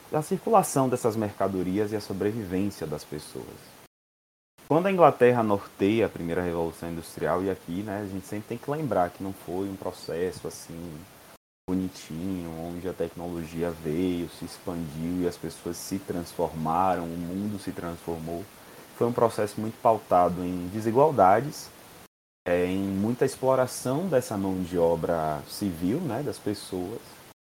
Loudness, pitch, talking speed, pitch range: -28 LUFS, 90 Hz, 145 wpm, 85-105 Hz